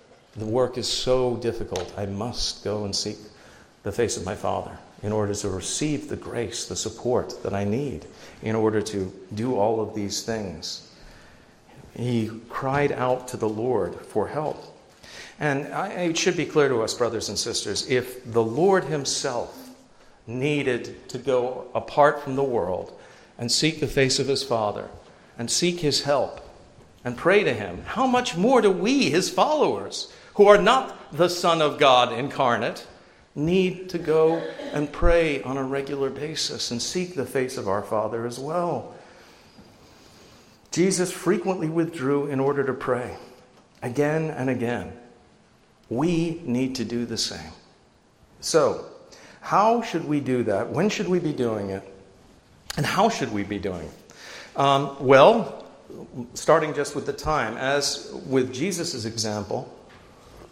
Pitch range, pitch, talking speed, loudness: 115-160 Hz, 135 Hz, 155 wpm, -24 LUFS